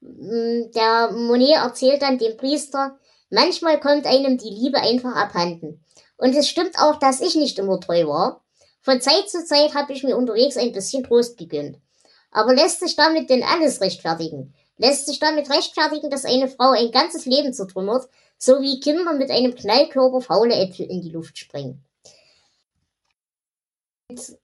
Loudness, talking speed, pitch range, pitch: -19 LUFS, 160 wpm, 225-285 Hz, 260 Hz